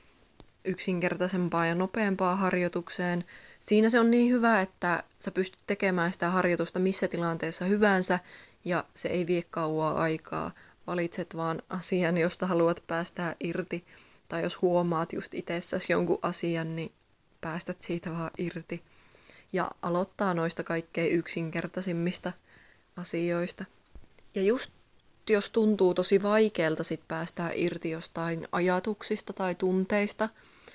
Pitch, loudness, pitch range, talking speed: 180 Hz, -28 LUFS, 170-190 Hz, 120 wpm